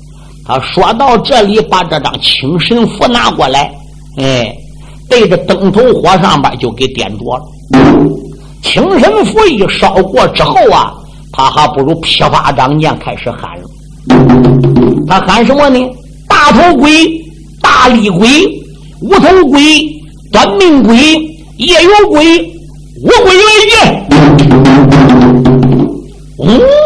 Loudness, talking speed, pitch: -6 LUFS, 165 characters per minute, 160 Hz